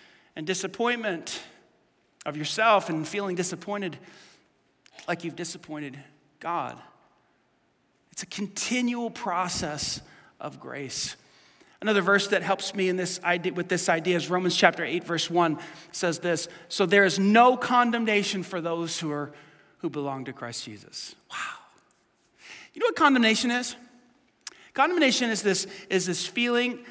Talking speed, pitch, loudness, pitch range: 140 wpm, 185 Hz, -26 LUFS, 170-220 Hz